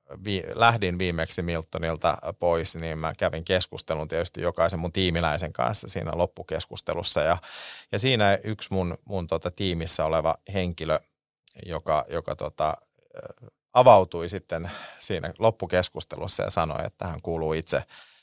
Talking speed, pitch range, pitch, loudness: 125 wpm, 80-95 Hz, 90 Hz, -26 LUFS